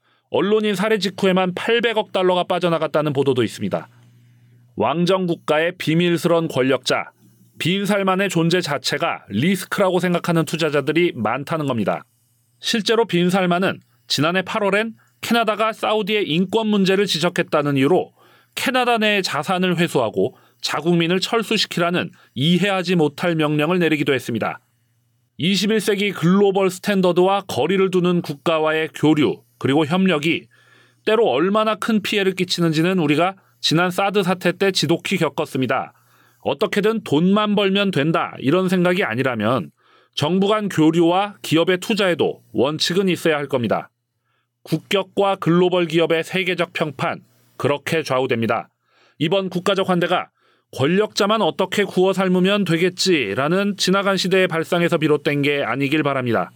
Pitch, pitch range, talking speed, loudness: 175 Hz, 155-195 Hz, 330 characters per minute, -19 LUFS